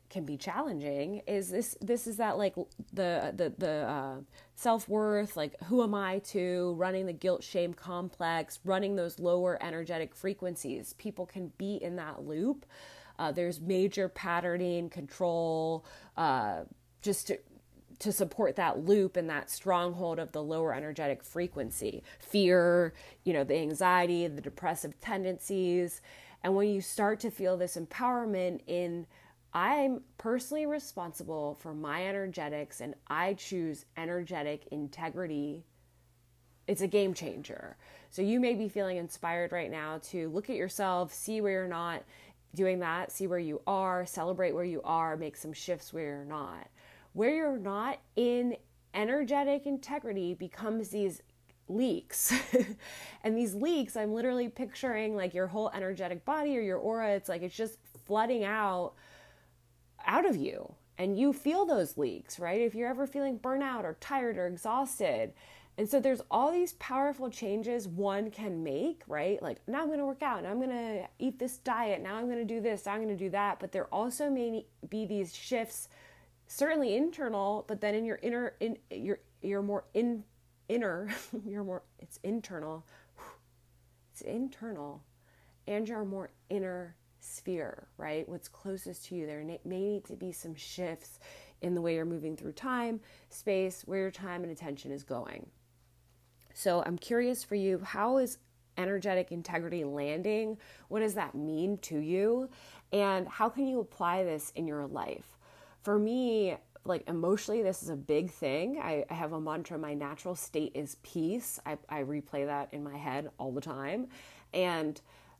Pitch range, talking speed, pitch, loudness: 160-215 Hz, 165 wpm, 185 Hz, -34 LUFS